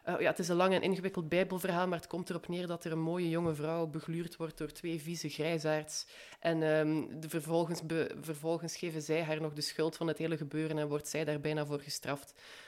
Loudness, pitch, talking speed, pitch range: -35 LUFS, 160 Hz, 230 wpm, 155-170 Hz